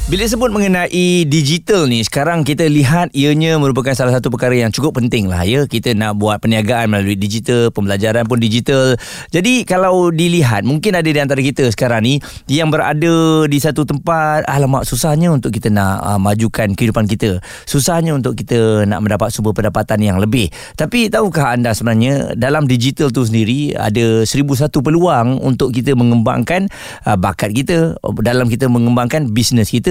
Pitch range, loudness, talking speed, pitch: 115-155 Hz, -14 LUFS, 165 wpm, 130 Hz